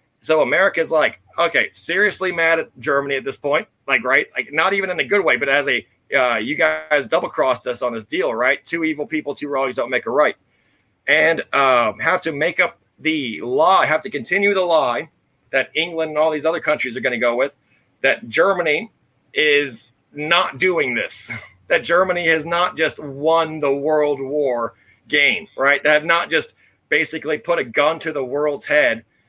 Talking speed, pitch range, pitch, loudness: 195 wpm, 140-175 Hz, 155 Hz, -18 LUFS